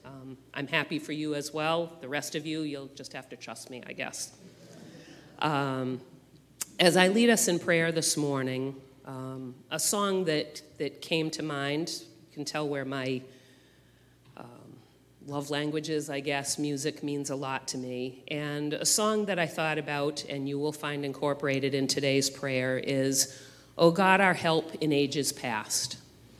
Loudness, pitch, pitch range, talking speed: -29 LUFS, 145 Hz, 135-155 Hz, 170 wpm